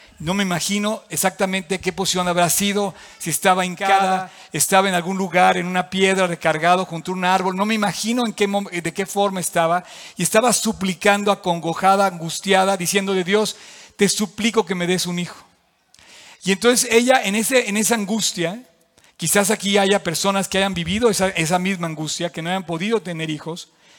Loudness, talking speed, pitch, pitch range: -19 LUFS, 180 wpm, 190 Hz, 175-205 Hz